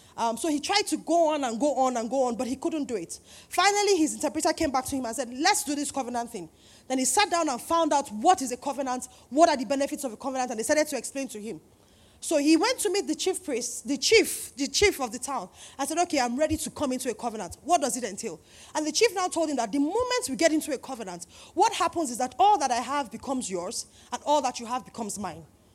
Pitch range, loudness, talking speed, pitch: 245-330 Hz, -26 LUFS, 275 wpm, 280 Hz